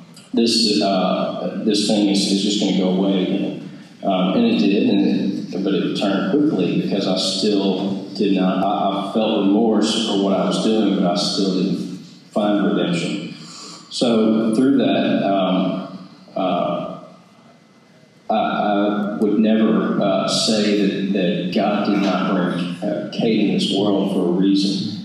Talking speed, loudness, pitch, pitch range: 160 wpm, -19 LUFS, 100 Hz, 95-105 Hz